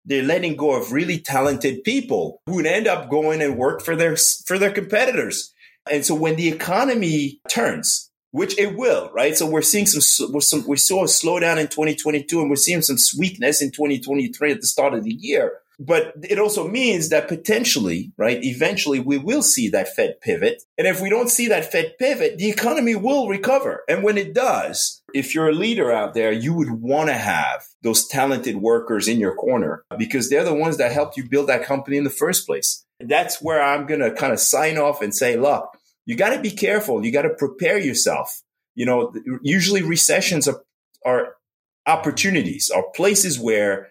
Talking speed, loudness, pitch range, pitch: 205 wpm, -19 LUFS, 140-225 Hz, 160 Hz